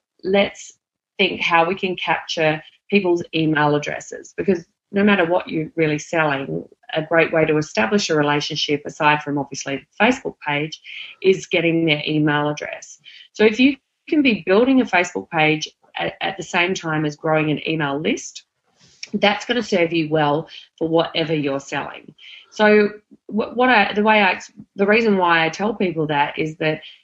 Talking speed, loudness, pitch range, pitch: 175 wpm, -19 LUFS, 155-200 Hz, 165 Hz